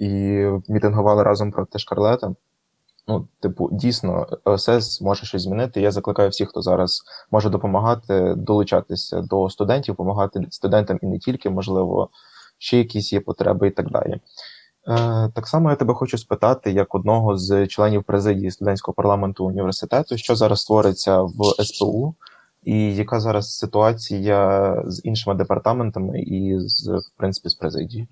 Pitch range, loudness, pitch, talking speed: 95-110 Hz, -20 LUFS, 100 Hz, 145 wpm